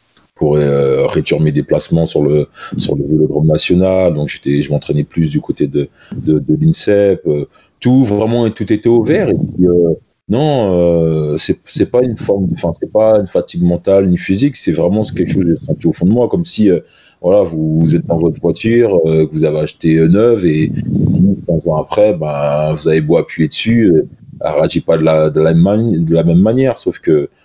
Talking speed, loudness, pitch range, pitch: 220 wpm, -13 LUFS, 75-105 Hz, 85 Hz